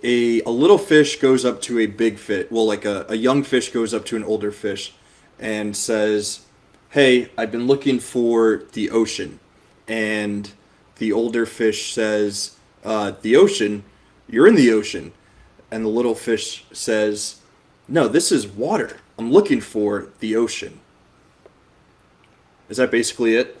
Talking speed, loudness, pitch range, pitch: 155 wpm, -19 LUFS, 105-120 Hz, 110 Hz